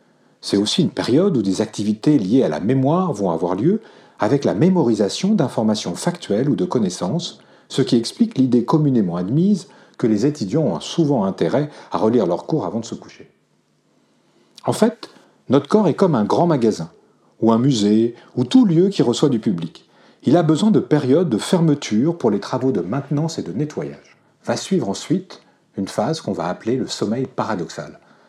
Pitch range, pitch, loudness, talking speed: 110-170 Hz, 140 Hz, -19 LUFS, 185 wpm